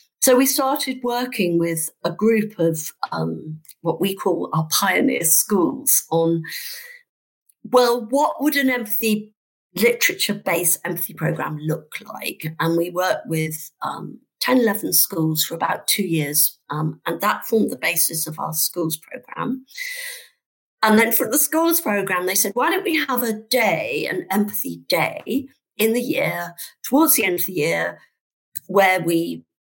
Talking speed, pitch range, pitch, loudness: 150 wpm, 165-255 Hz, 200 Hz, -20 LUFS